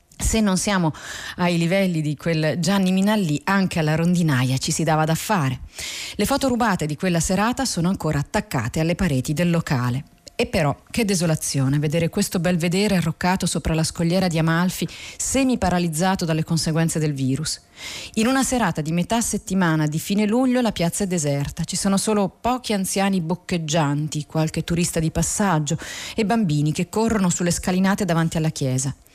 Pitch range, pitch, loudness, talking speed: 155-195 Hz, 175 Hz, -21 LUFS, 165 wpm